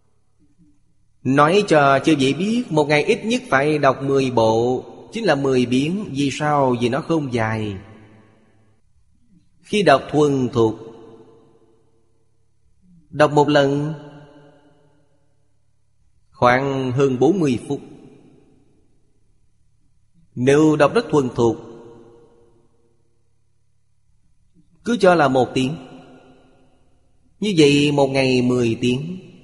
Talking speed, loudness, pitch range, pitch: 105 wpm, -18 LUFS, 115-145 Hz, 130 Hz